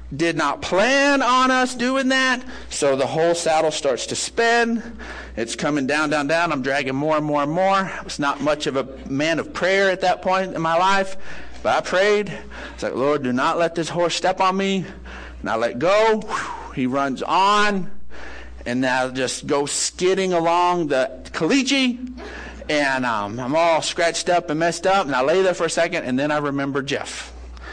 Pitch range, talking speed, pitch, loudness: 140-195 Hz, 195 wpm, 170 Hz, -20 LUFS